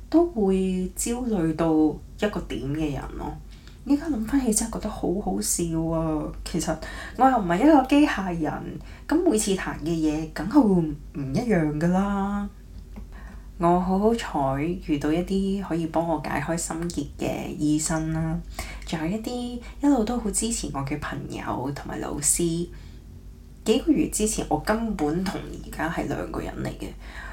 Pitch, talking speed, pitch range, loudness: 175 Hz, 230 characters per minute, 155-220 Hz, -25 LUFS